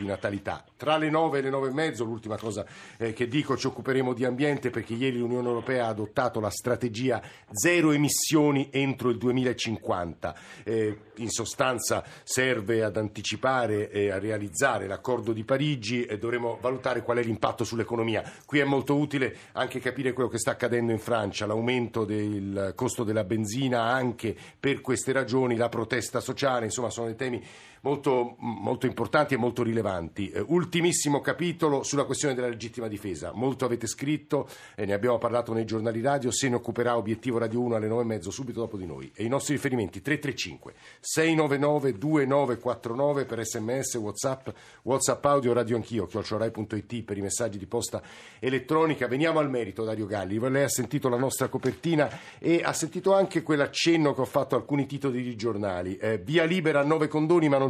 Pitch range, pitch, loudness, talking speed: 115-140 Hz, 125 Hz, -28 LUFS, 170 wpm